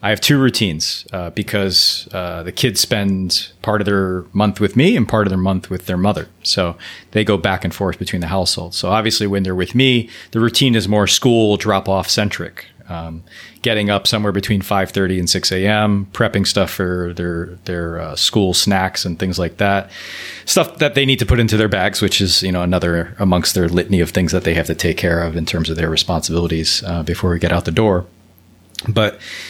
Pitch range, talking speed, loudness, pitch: 90-105 Hz, 220 wpm, -16 LUFS, 95 Hz